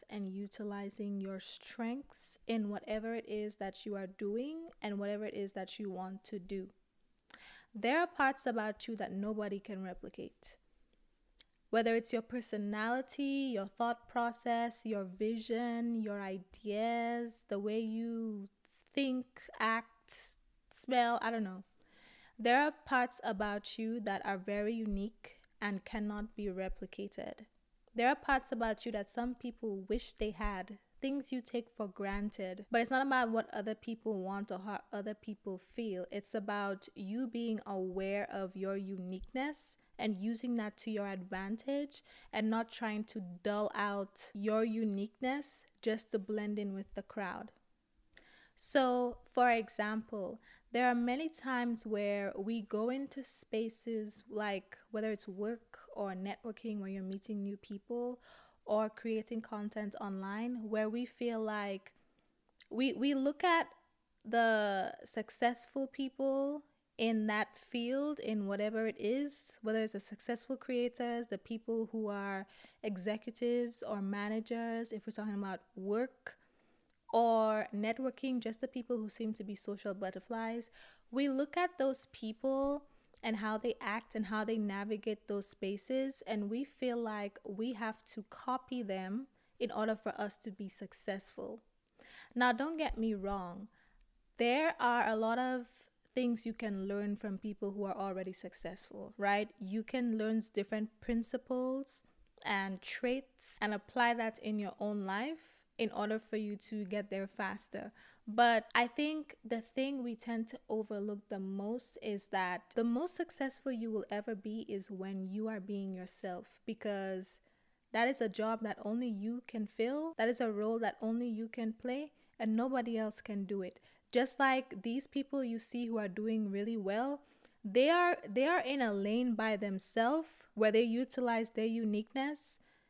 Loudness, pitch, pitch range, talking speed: -38 LUFS, 220 Hz, 205-245 Hz, 155 wpm